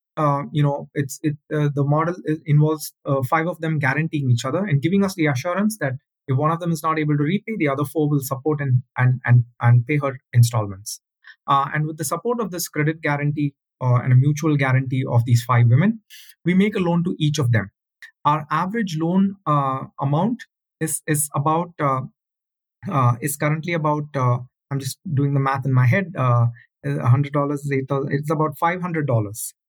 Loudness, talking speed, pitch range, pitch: -21 LUFS, 200 wpm, 135-160 Hz, 145 Hz